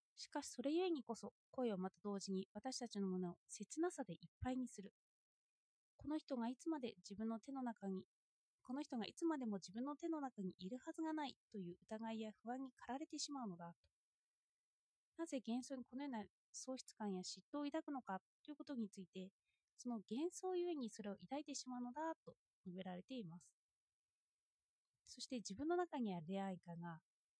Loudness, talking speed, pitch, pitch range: -49 LUFS, 360 characters per minute, 240 Hz, 195-285 Hz